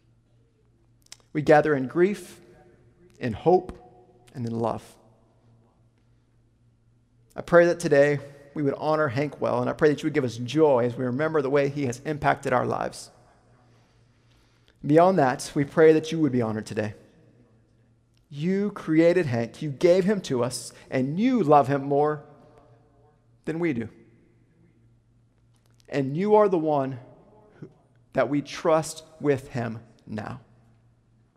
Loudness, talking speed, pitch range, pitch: -24 LUFS, 140 wpm, 115-150 Hz, 125 Hz